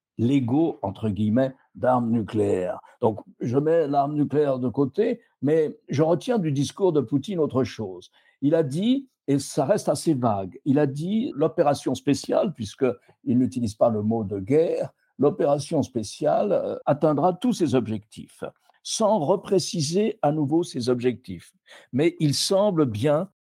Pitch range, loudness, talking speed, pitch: 125-170 Hz, -24 LUFS, 145 wpm, 145 Hz